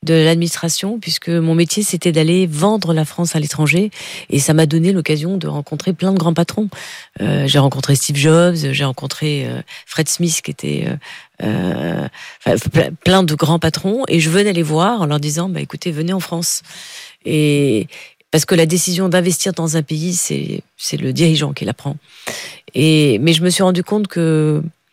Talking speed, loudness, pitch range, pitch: 190 wpm, -16 LUFS, 150-180 Hz, 165 Hz